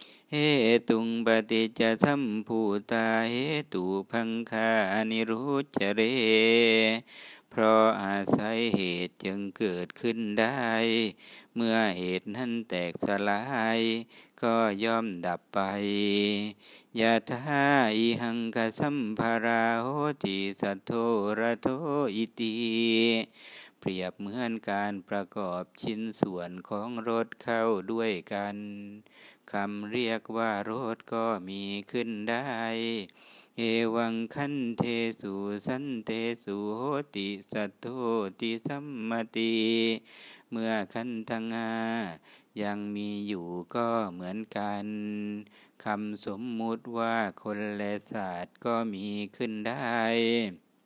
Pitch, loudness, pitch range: 115 Hz, -30 LUFS, 105-115 Hz